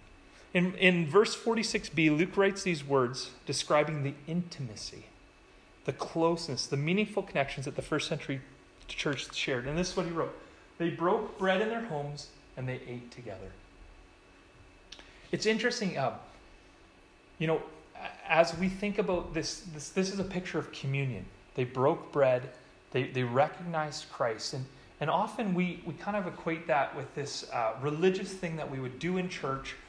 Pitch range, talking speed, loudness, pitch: 130-180 Hz, 170 wpm, -32 LUFS, 155 Hz